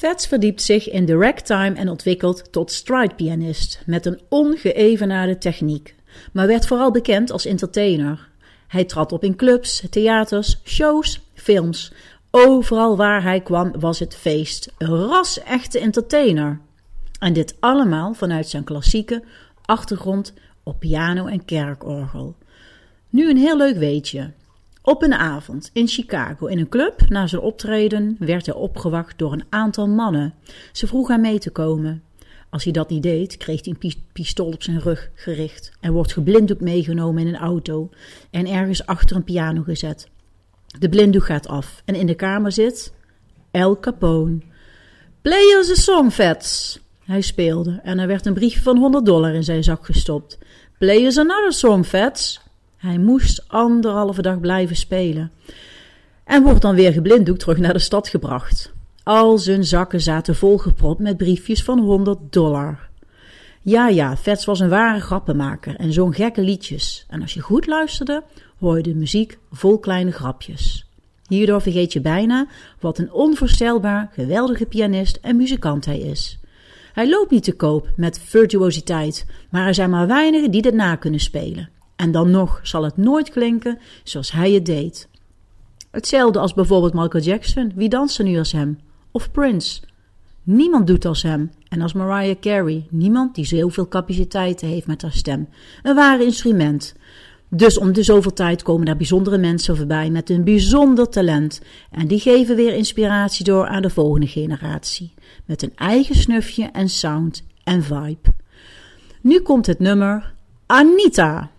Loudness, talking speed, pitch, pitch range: -18 LUFS, 160 wpm, 185 Hz, 160-220 Hz